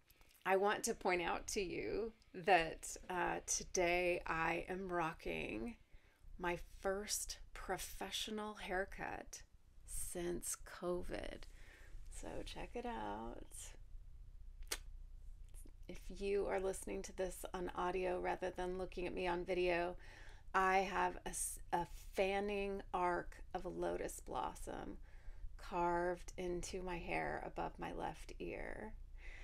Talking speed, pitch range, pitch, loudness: 115 wpm, 115-190 Hz, 180 Hz, -42 LUFS